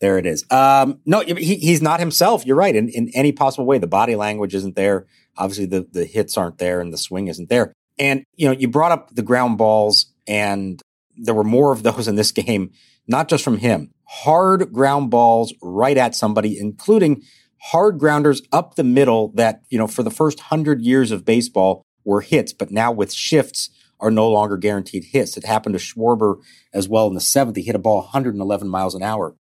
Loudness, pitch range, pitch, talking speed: -18 LUFS, 105-140 Hz, 115 Hz, 210 wpm